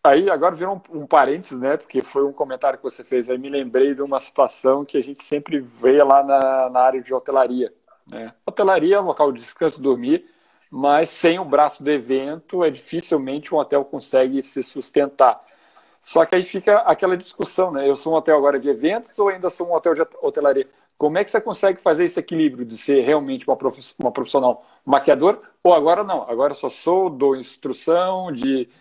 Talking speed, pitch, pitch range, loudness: 210 wpm, 145 Hz, 135-180 Hz, -19 LUFS